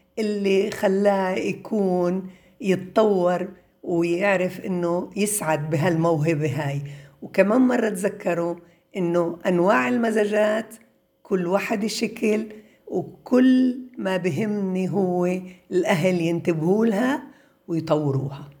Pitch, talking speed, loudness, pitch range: 185 Hz, 85 wpm, -23 LUFS, 175-215 Hz